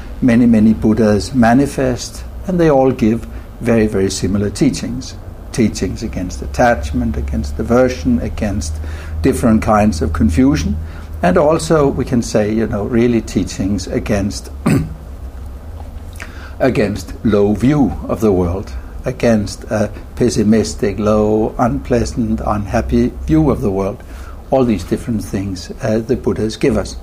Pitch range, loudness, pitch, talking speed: 85-120 Hz, -15 LUFS, 105 Hz, 125 wpm